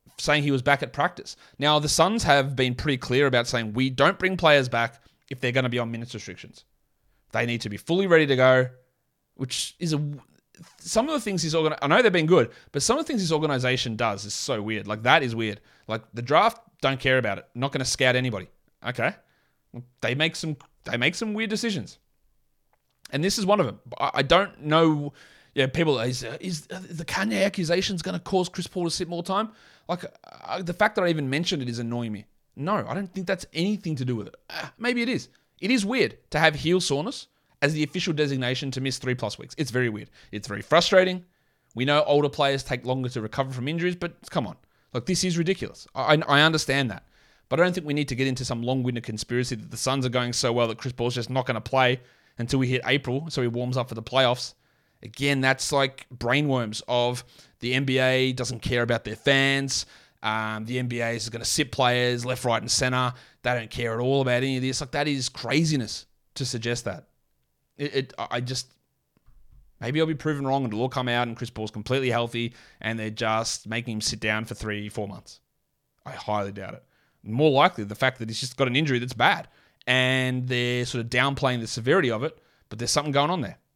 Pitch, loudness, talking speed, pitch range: 130 Hz, -25 LUFS, 230 wpm, 120-155 Hz